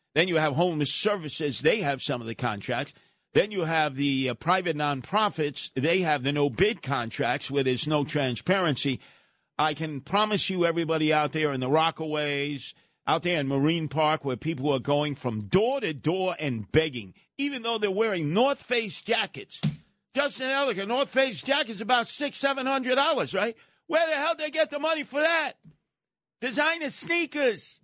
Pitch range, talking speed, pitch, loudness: 145-240 Hz, 180 wpm, 160 Hz, -26 LUFS